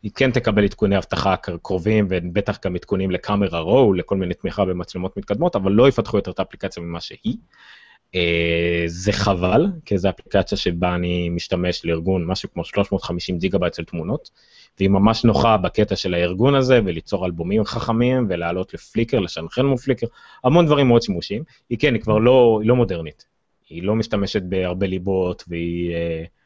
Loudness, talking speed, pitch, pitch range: -20 LUFS, 170 wpm, 95 Hz, 90-110 Hz